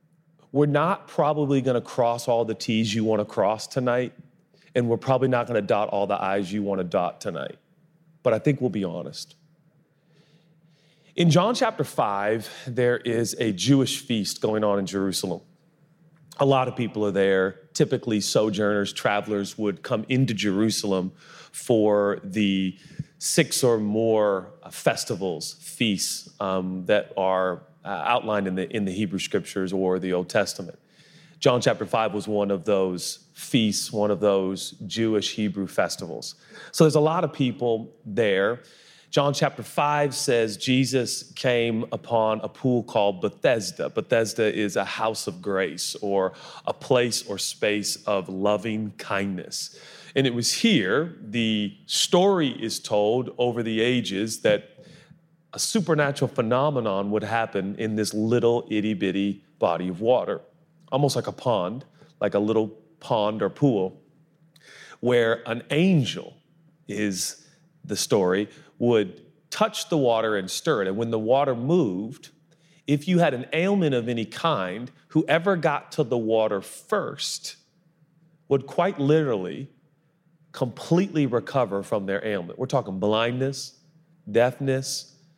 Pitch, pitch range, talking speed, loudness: 120 Hz, 105-155 Hz, 145 wpm, -24 LUFS